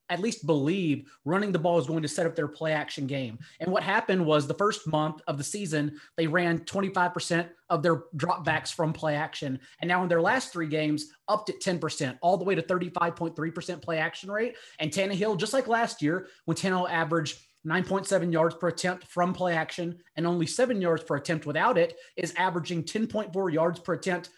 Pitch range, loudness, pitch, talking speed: 155-185 Hz, -28 LUFS, 170 Hz, 200 wpm